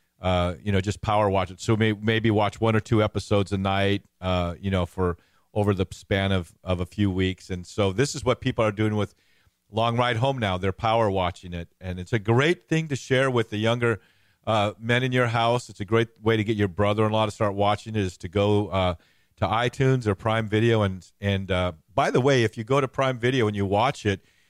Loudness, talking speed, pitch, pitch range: -24 LUFS, 245 wpm, 105 Hz, 95-115 Hz